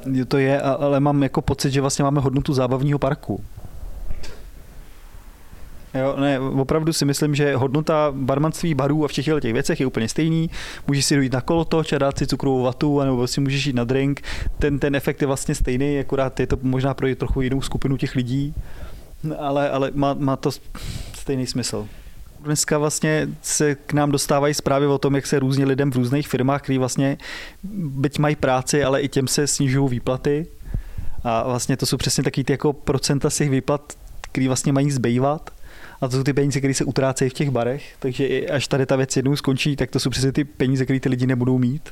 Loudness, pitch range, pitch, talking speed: -21 LUFS, 130-145 Hz, 140 Hz, 200 wpm